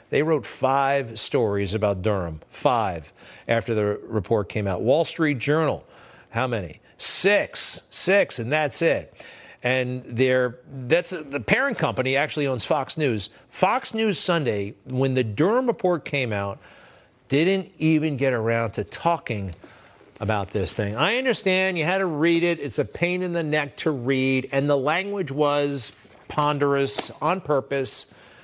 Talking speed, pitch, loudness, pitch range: 150 wpm, 140 Hz, -23 LUFS, 120-165 Hz